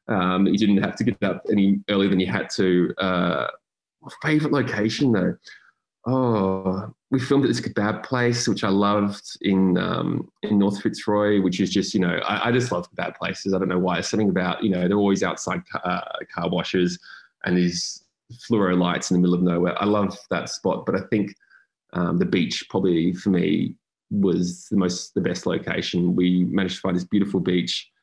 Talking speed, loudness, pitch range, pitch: 200 wpm, -23 LUFS, 90-105 Hz, 100 Hz